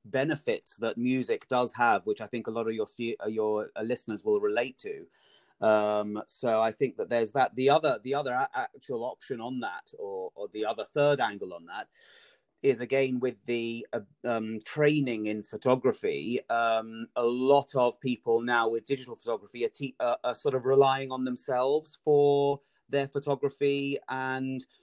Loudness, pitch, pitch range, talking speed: -29 LUFS, 130 Hz, 115-150 Hz, 170 wpm